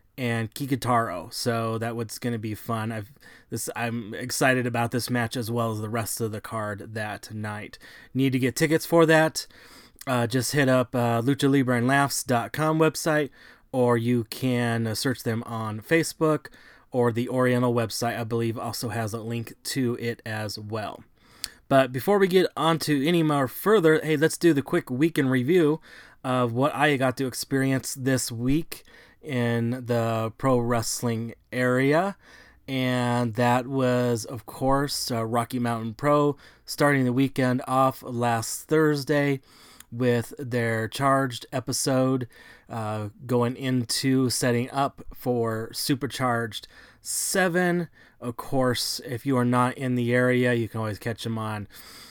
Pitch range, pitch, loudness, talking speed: 115-140 Hz, 125 Hz, -25 LUFS, 155 wpm